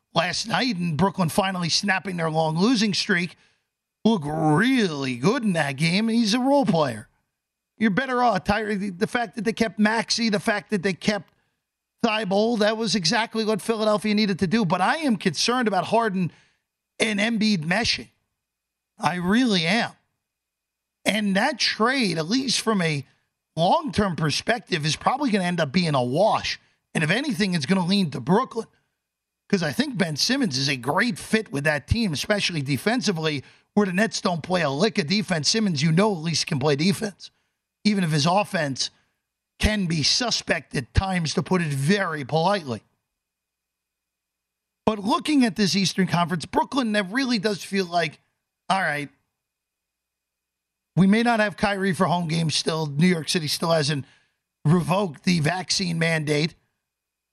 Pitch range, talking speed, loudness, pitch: 155-215 Hz, 170 wpm, -23 LUFS, 190 Hz